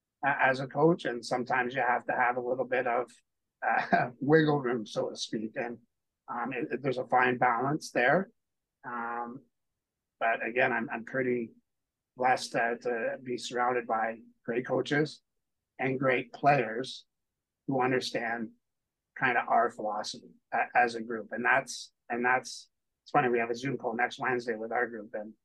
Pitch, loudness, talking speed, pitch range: 125 Hz, -30 LUFS, 165 wpm, 115-130 Hz